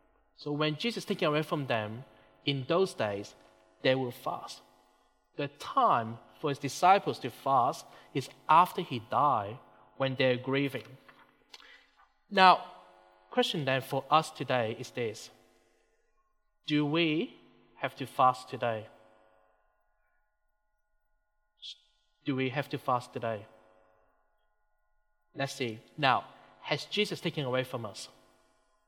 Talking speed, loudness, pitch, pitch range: 120 wpm, -30 LUFS, 145 Hz, 125-195 Hz